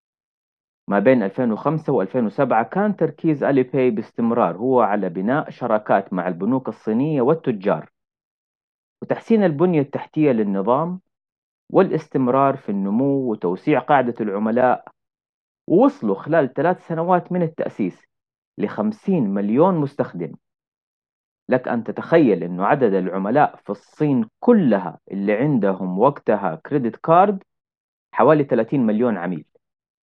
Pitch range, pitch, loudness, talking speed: 120-185 Hz, 145 Hz, -20 LUFS, 110 wpm